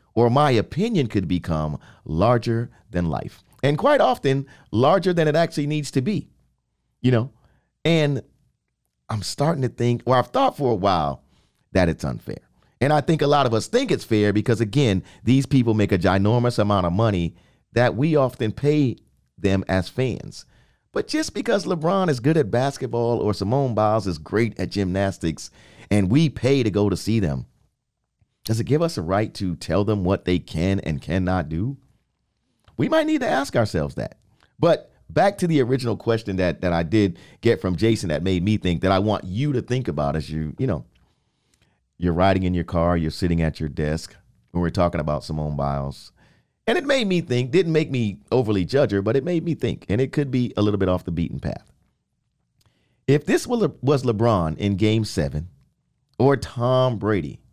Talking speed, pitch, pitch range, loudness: 195 wpm, 110 Hz, 90-135 Hz, -22 LUFS